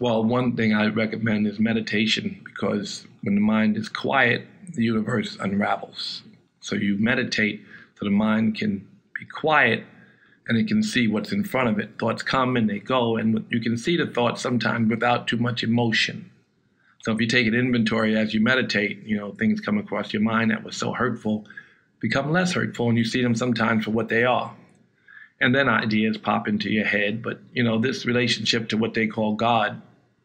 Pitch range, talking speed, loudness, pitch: 110-120 Hz, 195 wpm, -23 LUFS, 115 Hz